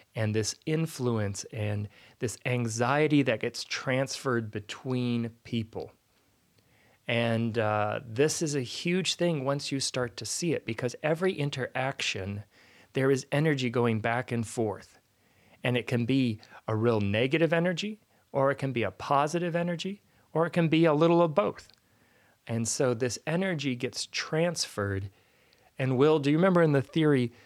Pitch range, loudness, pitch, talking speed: 115-155 Hz, -29 LUFS, 125 Hz, 155 wpm